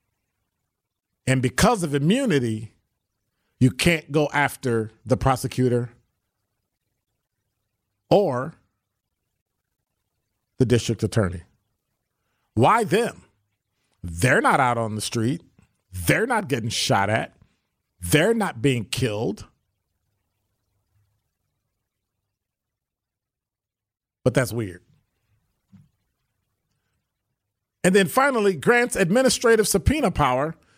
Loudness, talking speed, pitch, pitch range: -22 LUFS, 80 wpm, 115 Hz, 100-130 Hz